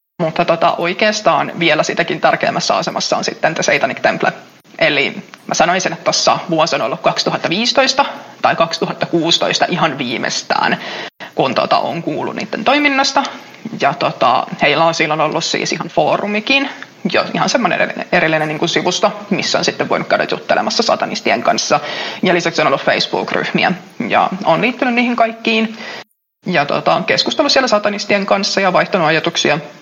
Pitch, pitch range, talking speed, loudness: 205 Hz, 165-245 Hz, 150 wpm, -15 LUFS